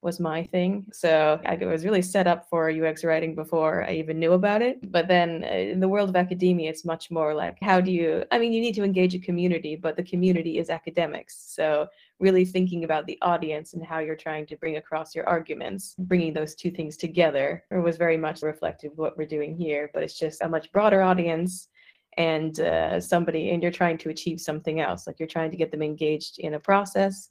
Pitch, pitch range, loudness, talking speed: 165 Hz, 155-180 Hz, -25 LUFS, 225 wpm